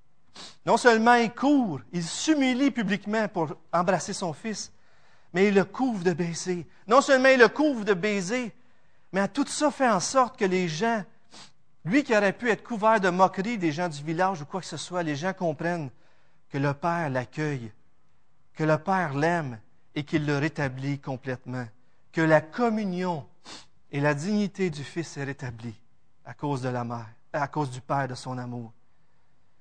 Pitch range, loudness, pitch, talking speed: 140-210 Hz, -26 LUFS, 170 Hz, 180 wpm